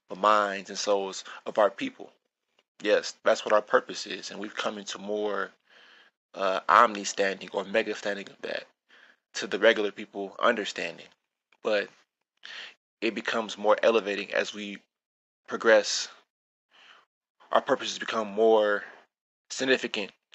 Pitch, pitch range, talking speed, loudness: 105 Hz, 100-110 Hz, 125 wpm, -27 LUFS